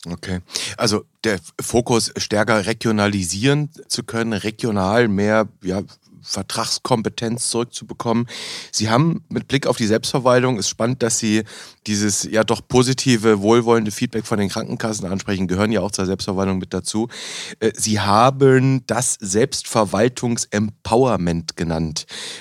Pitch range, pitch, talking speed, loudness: 100-120 Hz, 110 Hz, 125 wpm, -19 LUFS